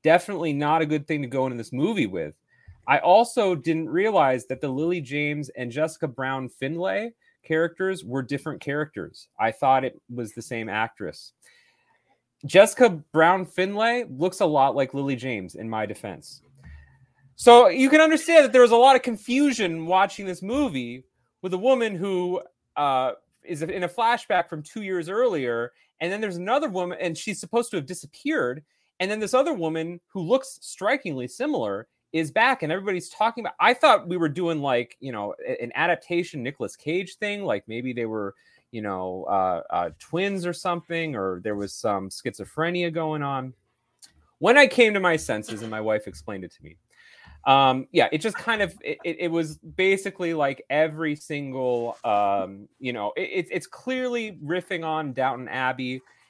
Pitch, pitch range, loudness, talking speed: 160 Hz, 130-195 Hz, -23 LUFS, 175 wpm